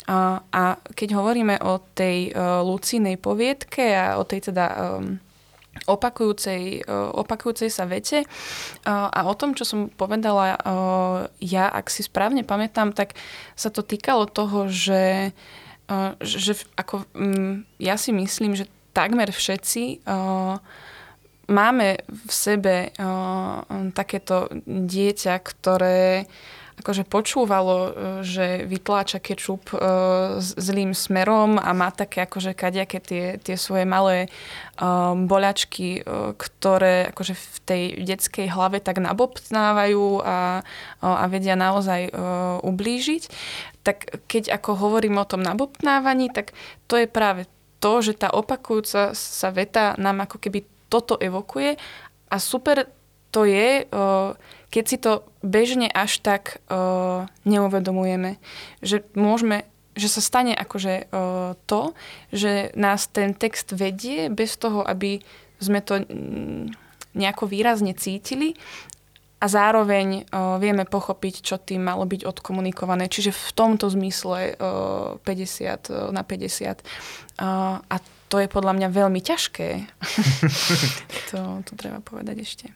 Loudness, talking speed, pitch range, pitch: -23 LUFS, 115 wpm, 185-210 Hz, 195 Hz